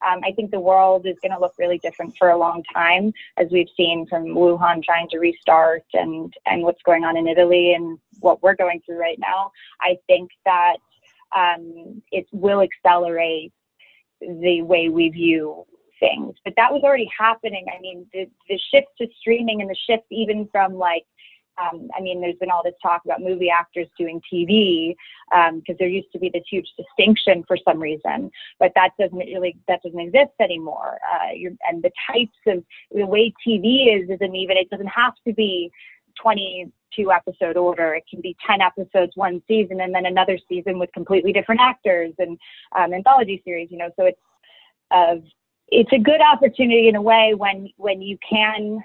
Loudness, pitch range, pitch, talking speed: -19 LUFS, 175-205 Hz, 185 Hz, 190 wpm